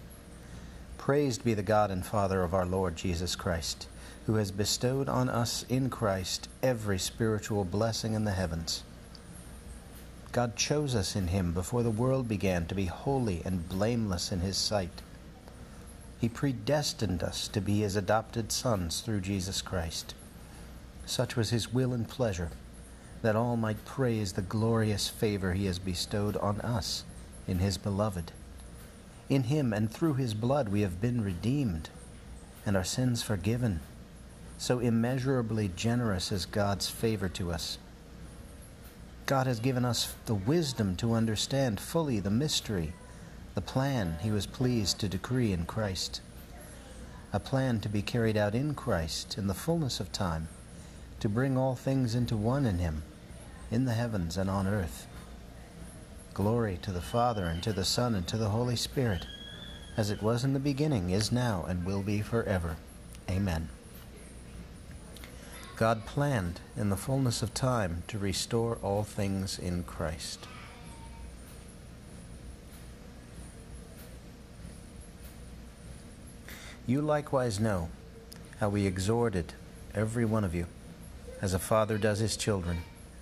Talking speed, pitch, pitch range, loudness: 140 wpm, 105 Hz, 90-115 Hz, -31 LUFS